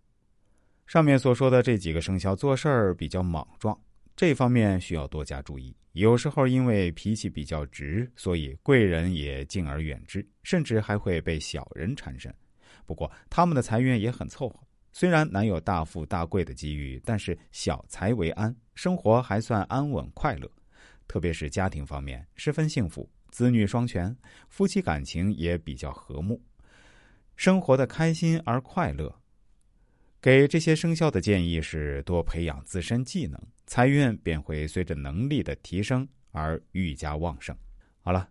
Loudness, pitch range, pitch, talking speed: -27 LUFS, 80-125 Hz, 100 Hz, 245 characters per minute